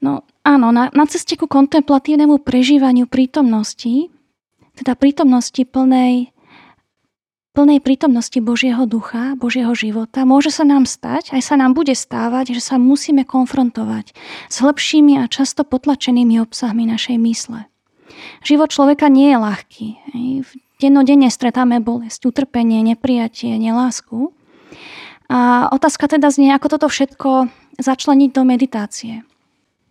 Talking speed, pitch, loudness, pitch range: 120 wpm, 260 Hz, -14 LUFS, 240-285 Hz